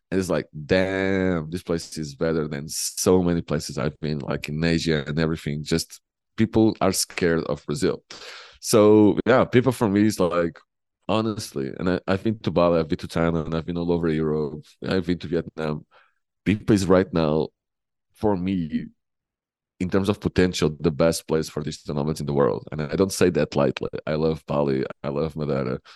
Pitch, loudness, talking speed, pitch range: 85 Hz, -23 LUFS, 190 wpm, 75-95 Hz